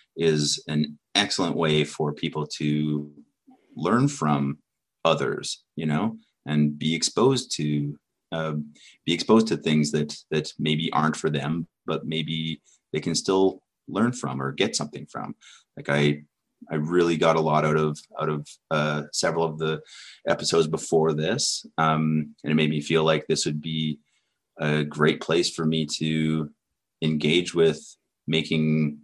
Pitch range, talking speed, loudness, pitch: 75-80 Hz, 155 wpm, -25 LUFS, 75 Hz